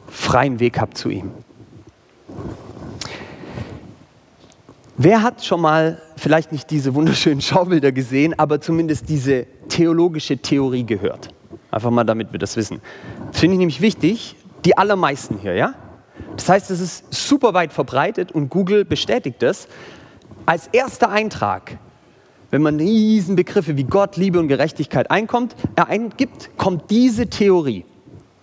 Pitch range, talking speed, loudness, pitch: 140-190 Hz, 135 wpm, -18 LUFS, 160 Hz